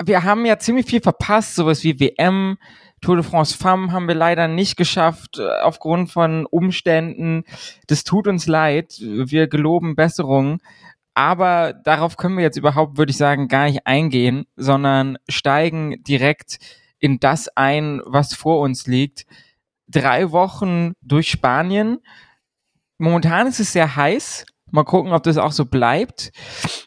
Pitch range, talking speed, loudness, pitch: 145-180 Hz, 145 wpm, -18 LUFS, 160 Hz